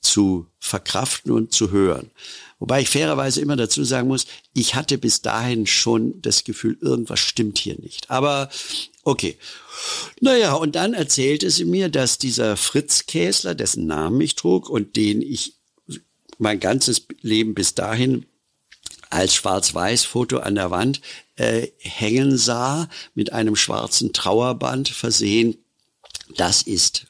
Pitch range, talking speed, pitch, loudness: 110-135 Hz, 140 wpm, 120 Hz, -20 LUFS